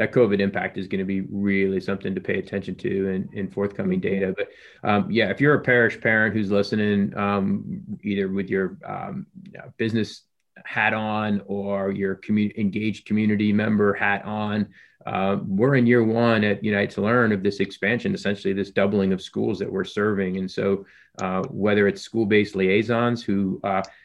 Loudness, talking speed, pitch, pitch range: -23 LUFS, 190 wpm, 105 Hz, 100-115 Hz